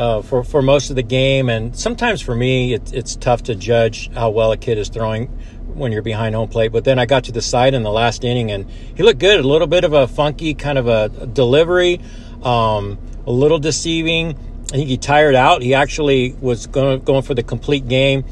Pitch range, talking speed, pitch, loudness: 115-140 Hz, 230 wpm, 125 Hz, -16 LUFS